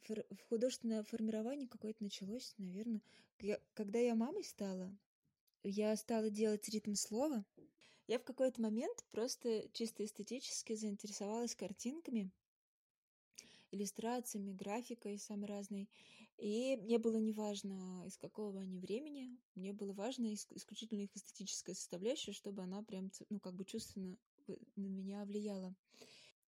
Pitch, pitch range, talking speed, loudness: 215 Hz, 200-230 Hz, 125 wpm, -44 LUFS